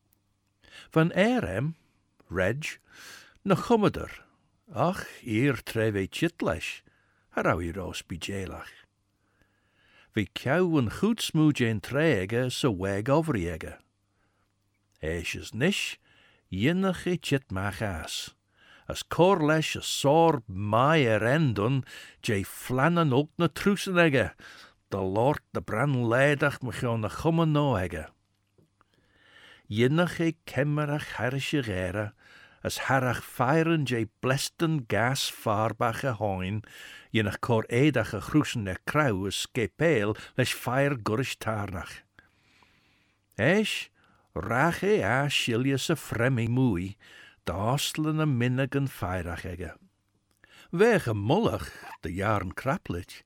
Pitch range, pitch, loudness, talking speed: 100-150 Hz, 120 Hz, -27 LUFS, 90 wpm